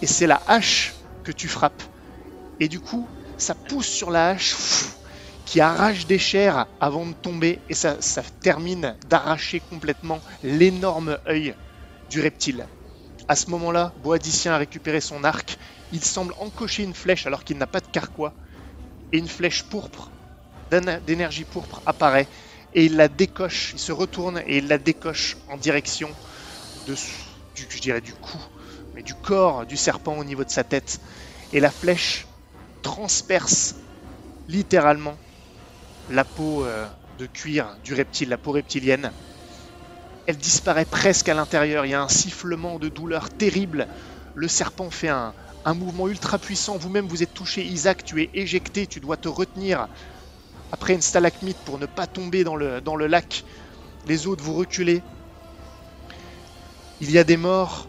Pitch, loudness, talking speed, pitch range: 160 Hz, -23 LUFS, 160 wpm, 140-180 Hz